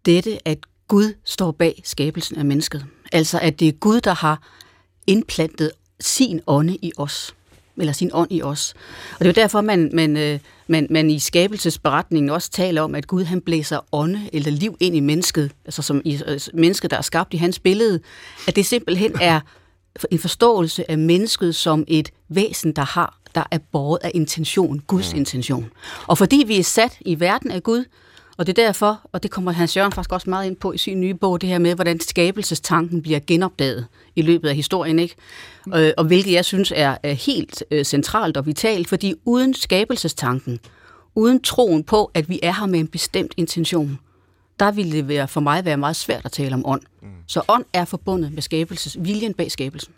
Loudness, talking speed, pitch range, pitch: -19 LUFS, 195 wpm, 150-185 Hz, 165 Hz